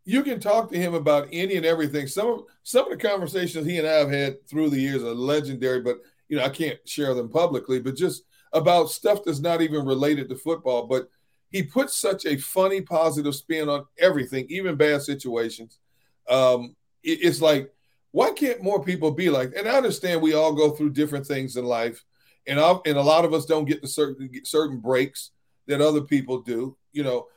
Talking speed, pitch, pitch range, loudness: 210 wpm, 150 Hz, 135-170 Hz, -24 LUFS